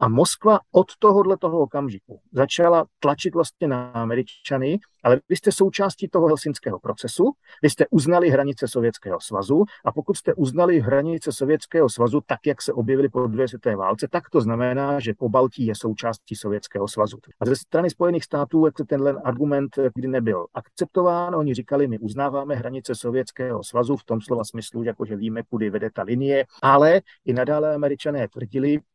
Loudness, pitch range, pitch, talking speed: -22 LUFS, 120-155 Hz, 140 Hz, 170 wpm